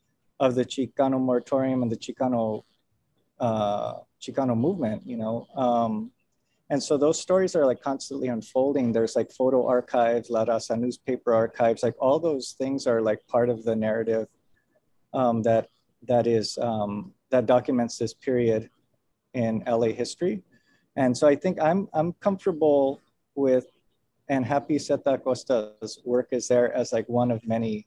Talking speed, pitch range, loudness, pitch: 155 wpm, 115-135 Hz, -25 LUFS, 125 Hz